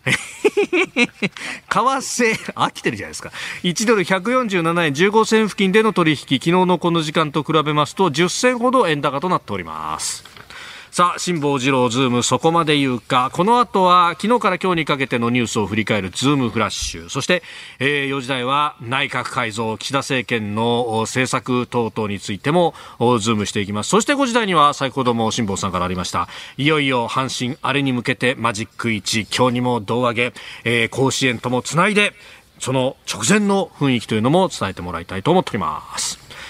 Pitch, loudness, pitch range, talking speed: 135 Hz, -18 LUFS, 120-180 Hz, 360 characters per minute